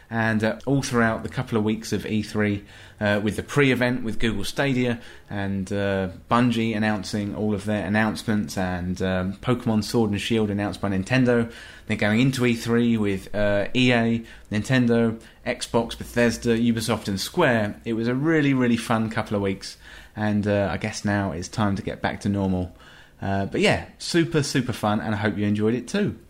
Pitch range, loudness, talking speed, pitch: 100-120 Hz, -24 LUFS, 185 wpm, 110 Hz